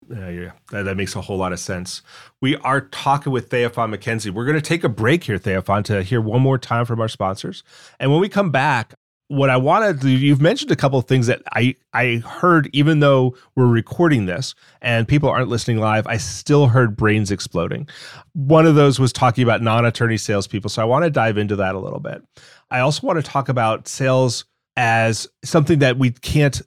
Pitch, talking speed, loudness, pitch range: 125 Hz, 220 wpm, -18 LUFS, 110-140 Hz